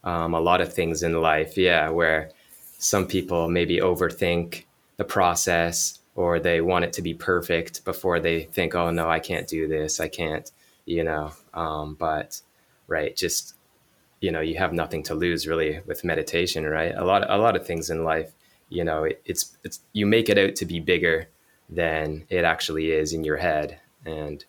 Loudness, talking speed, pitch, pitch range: -24 LUFS, 190 wpm, 80 Hz, 80-85 Hz